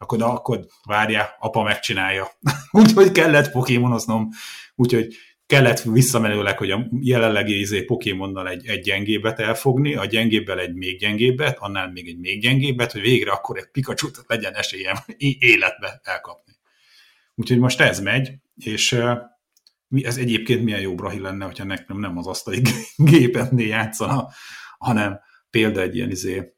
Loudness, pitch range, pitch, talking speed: -20 LUFS, 100-125 Hz, 115 Hz, 140 wpm